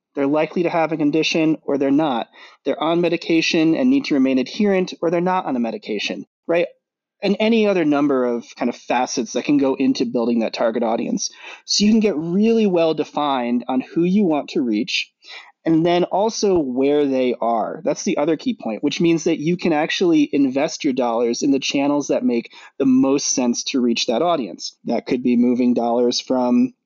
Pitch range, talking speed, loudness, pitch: 130-195 Hz, 205 wpm, -19 LUFS, 155 Hz